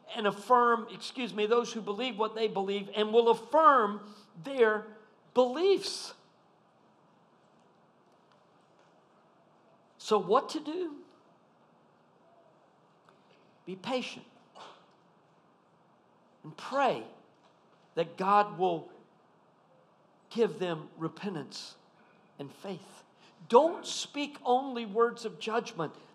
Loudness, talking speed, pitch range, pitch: -30 LUFS, 85 wpm, 200-250 Hz, 220 Hz